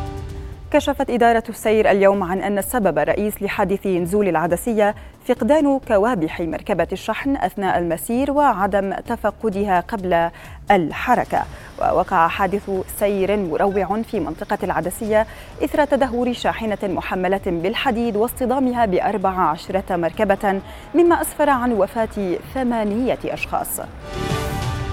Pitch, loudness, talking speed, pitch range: 205 Hz, -20 LUFS, 105 wpm, 190-235 Hz